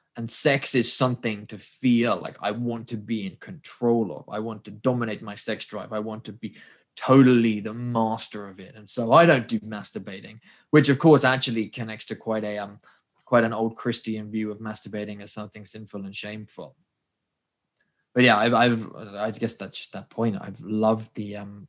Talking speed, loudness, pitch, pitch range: 200 wpm, -24 LUFS, 110 Hz, 105-120 Hz